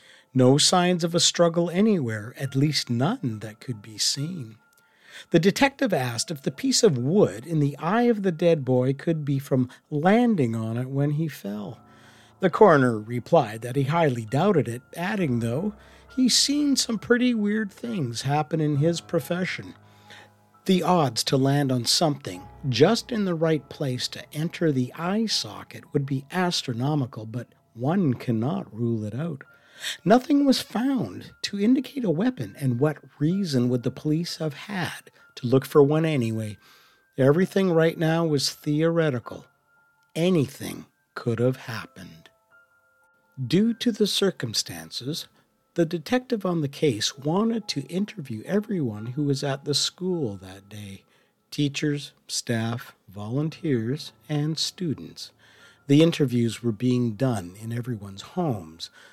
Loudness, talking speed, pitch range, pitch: -24 LUFS, 145 wpm, 120-180 Hz, 145 Hz